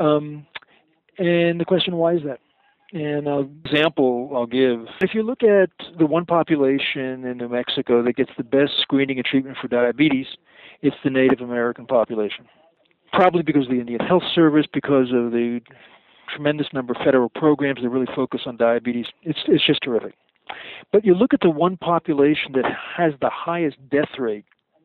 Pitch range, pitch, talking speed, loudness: 125-165 Hz, 140 Hz, 175 wpm, -20 LUFS